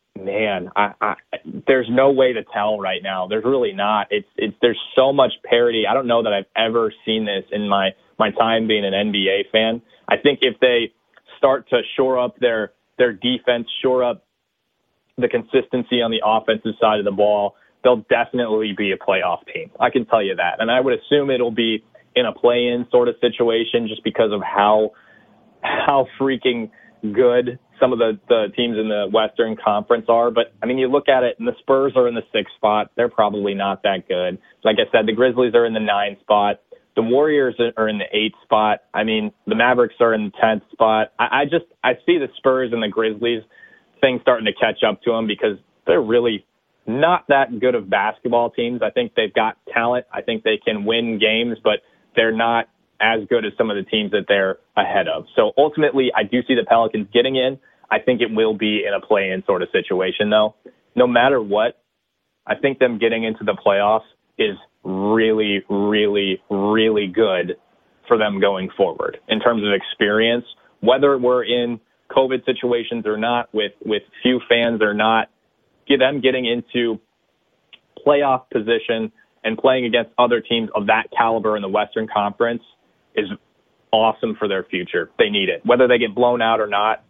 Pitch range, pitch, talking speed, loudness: 105-125 Hz, 115 Hz, 195 wpm, -19 LUFS